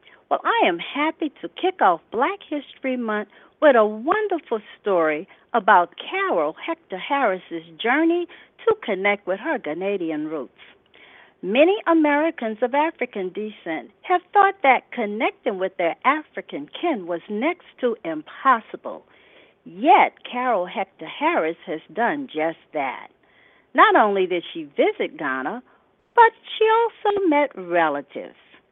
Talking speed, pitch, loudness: 125 wpm, 260 Hz, -22 LUFS